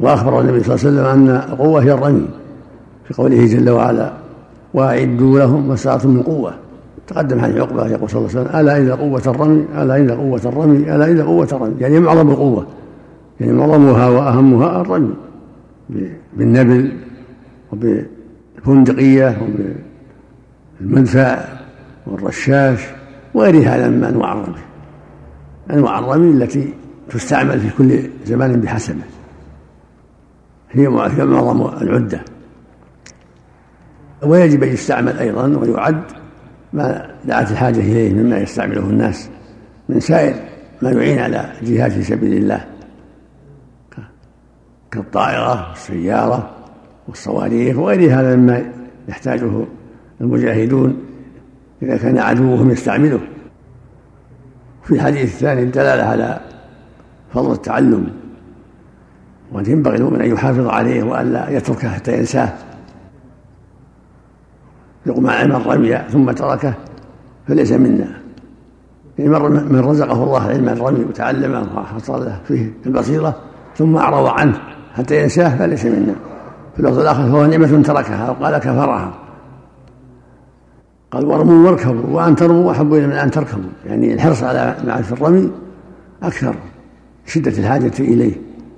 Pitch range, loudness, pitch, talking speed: 115-145 Hz, -14 LUFS, 130 Hz, 110 wpm